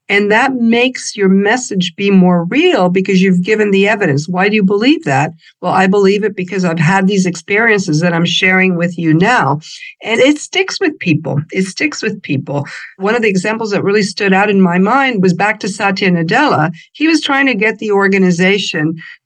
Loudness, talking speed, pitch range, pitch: -12 LUFS, 205 wpm, 180-215 Hz, 195 Hz